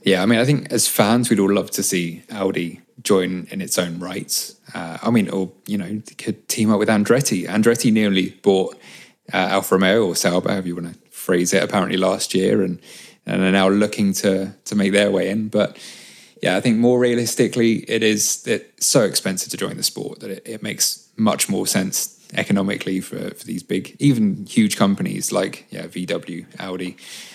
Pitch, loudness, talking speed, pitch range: 100 Hz, -19 LUFS, 200 wpm, 95-115 Hz